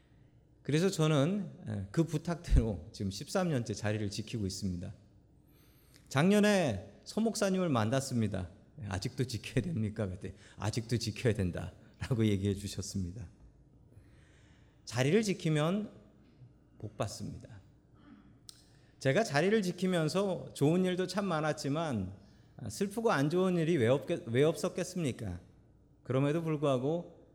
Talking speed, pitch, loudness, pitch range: 265 characters per minute, 130 Hz, -33 LUFS, 105-165 Hz